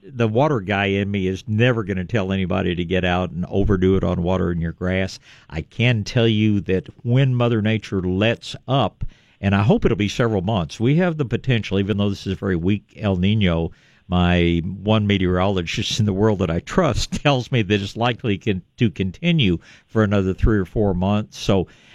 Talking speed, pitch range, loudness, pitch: 205 wpm, 95-115 Hz, -20 LUFS, 100 Hz